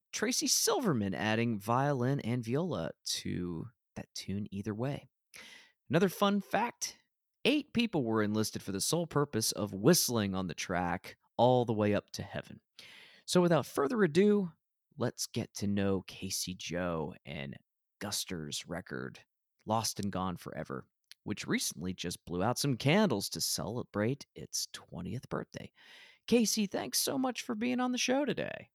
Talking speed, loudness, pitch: 150 wpm, -33 LUFS, 120 Hz